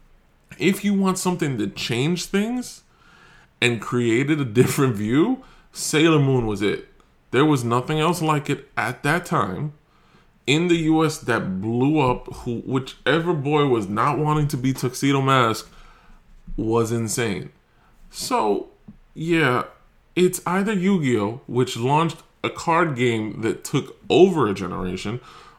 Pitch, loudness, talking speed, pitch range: 140 Hz, -22 LUFS, 135 wpm, 120-165 Hz